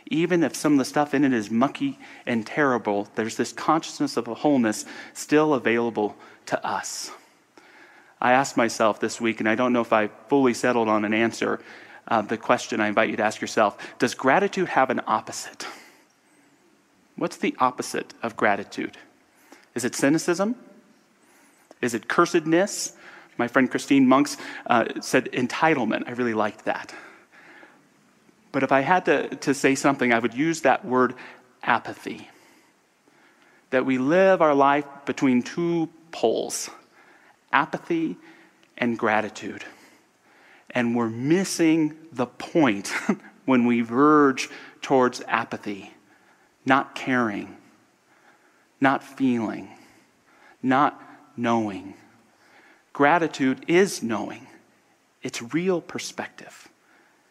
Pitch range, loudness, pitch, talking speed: 115-160 Hz, -23 LUFS, 135 Hz, 125 wpm